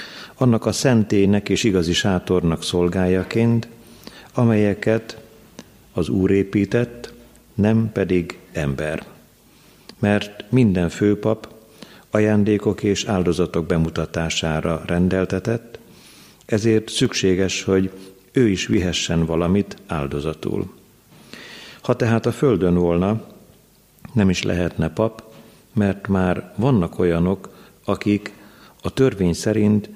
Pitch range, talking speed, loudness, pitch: 90-110 Hz, 95 wpm, -20 LUFS, 100 Hz